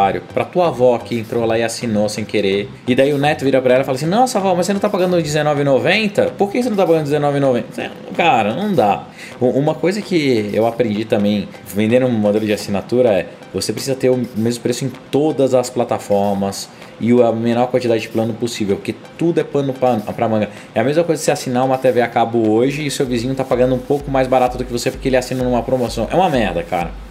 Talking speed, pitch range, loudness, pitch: 235 wpm, 115-140 Hz, -17 LUFS, 125 Hz